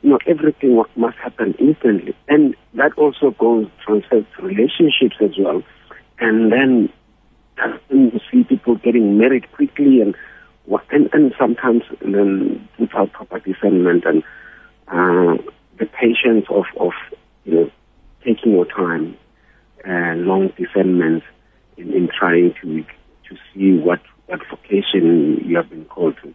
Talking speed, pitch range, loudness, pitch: 135 wpm, 95-145 Hz, -16 LUFS, 110 Hz